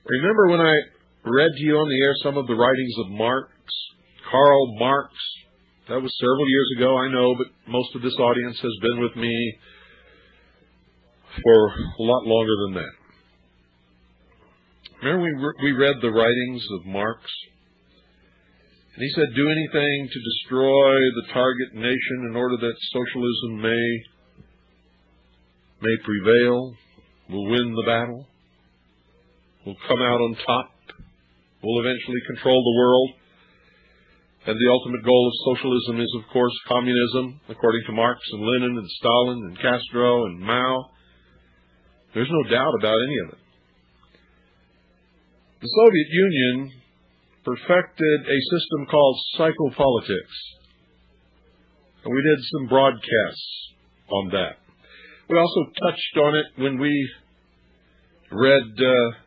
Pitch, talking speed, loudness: 120 Hz, 135 wpm, -21 LUFS